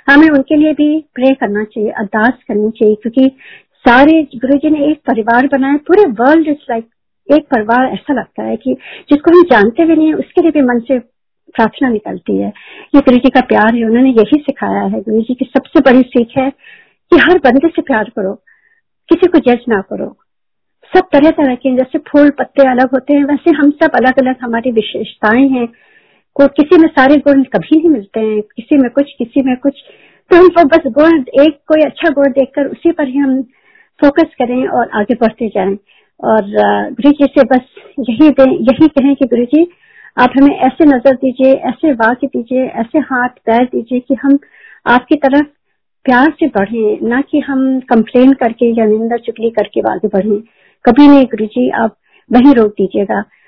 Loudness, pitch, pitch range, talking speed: -11 LUFS, 265 Hz, 235-300 Hz, 195 wpm